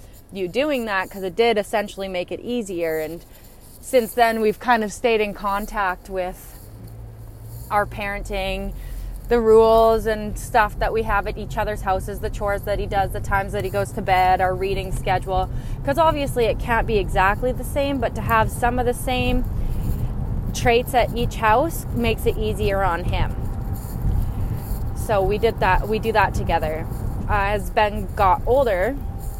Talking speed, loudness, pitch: 170 wpm, -22 LUFS, 185 Hz